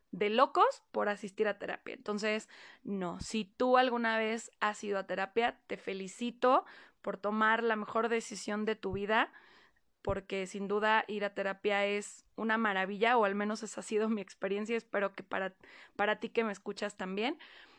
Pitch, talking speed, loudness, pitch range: 215 Hz, 175 wpm, -33 LUFS, 200-230 Hz